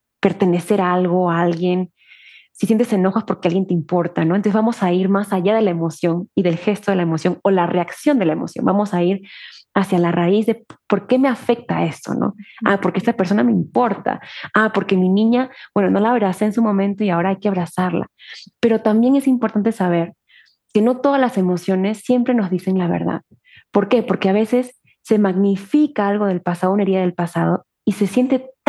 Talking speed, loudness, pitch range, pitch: 215 wpm, -18 LUFS, 180-225 Hz, 200 Hz